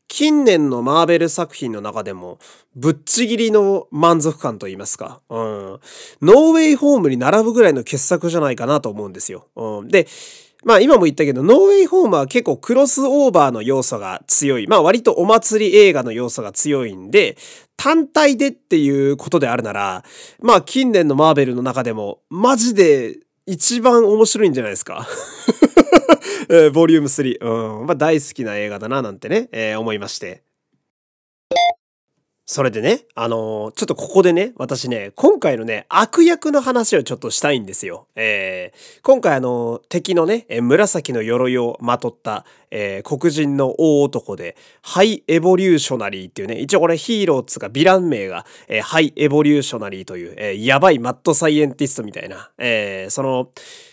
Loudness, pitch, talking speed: -15 LUFS, 165 Hz, 360 characters per minute